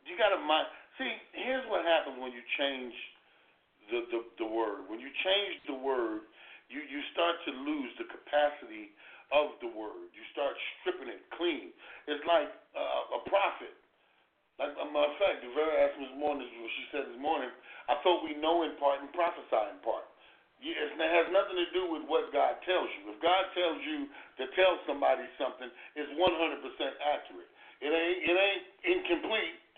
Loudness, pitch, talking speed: -32 LUFS, 175 Hz, 185 wpm